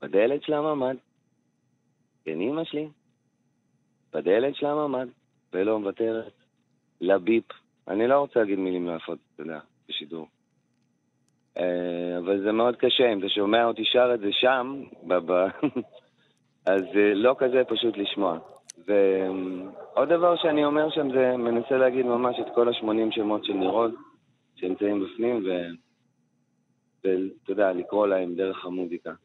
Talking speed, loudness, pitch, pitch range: 130 wpm, -25 LUFS, 110 Hz, 90-130 Hz